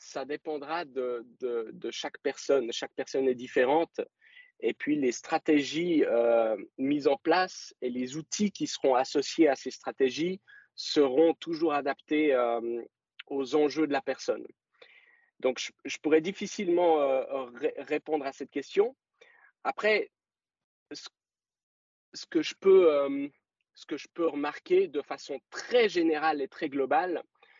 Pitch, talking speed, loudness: 160 Hz, 145 wpm, -29 LUFS